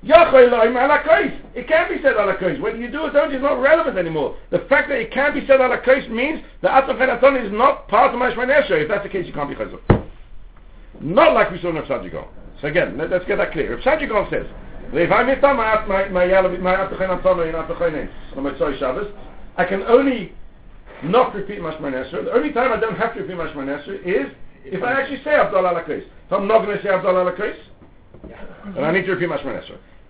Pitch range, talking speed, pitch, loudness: 185-275 Hz, 195 wpm, 225 Hz, -18 LUFS